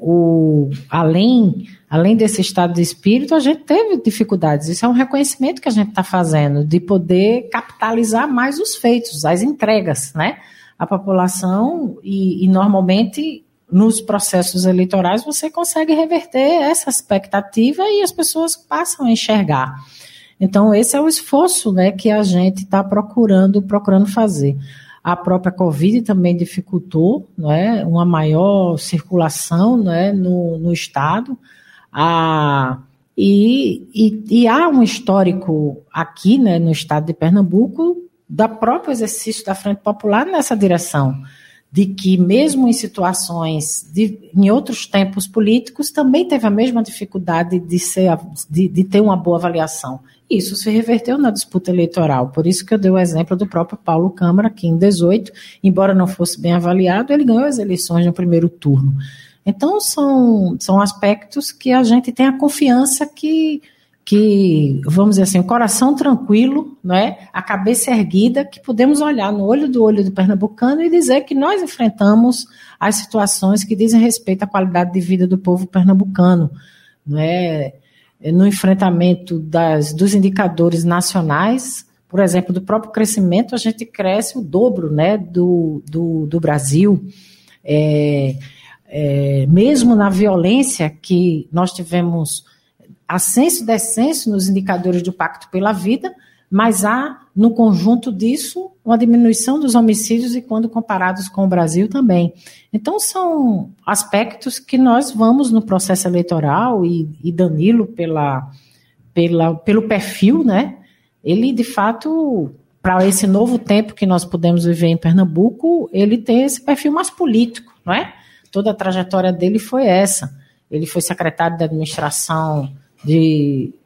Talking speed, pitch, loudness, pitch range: 145 wpm, 195 Hz, -15 LUFS, 175-235 Hz